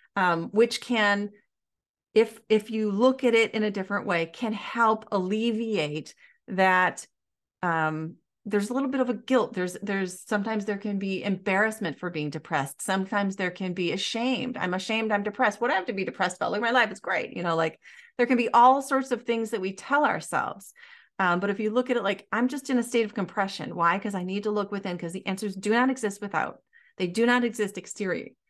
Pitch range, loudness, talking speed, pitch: 185-235 Hz, -26 LUFS, 220 wpm, 210 Hz